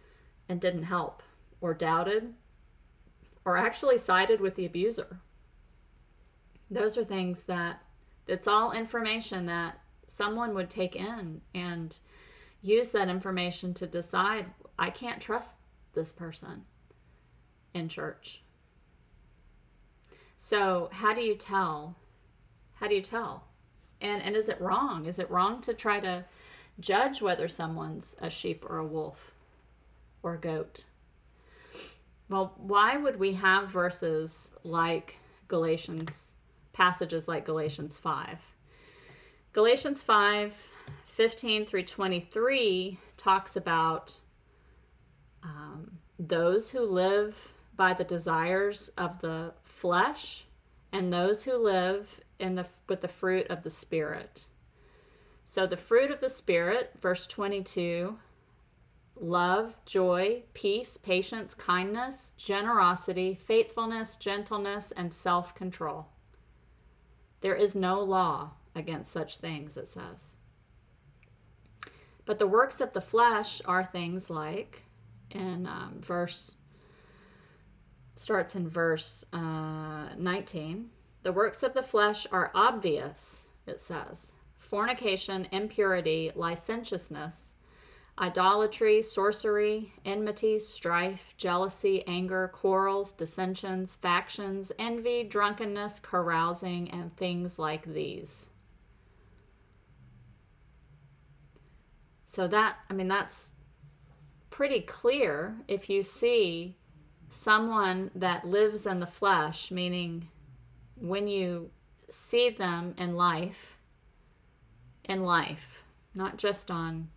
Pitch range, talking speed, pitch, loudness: 160-205 Hz, 105 wpm, 180 Hz, -30 LUFS